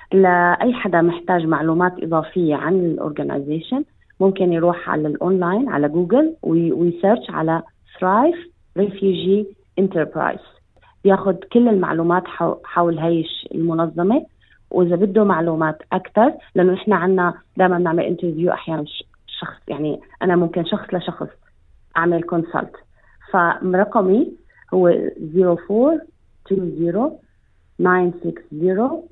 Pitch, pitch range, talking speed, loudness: 180 Hz, 170-200 Hz, 105 wpm, -19 LUFS